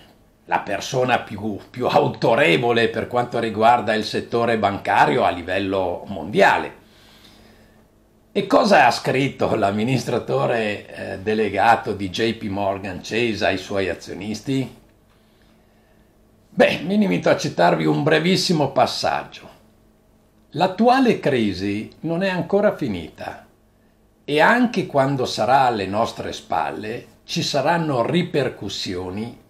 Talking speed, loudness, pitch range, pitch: 105 wpm, -20 LUFS, 105-135 Hz, 110 Hz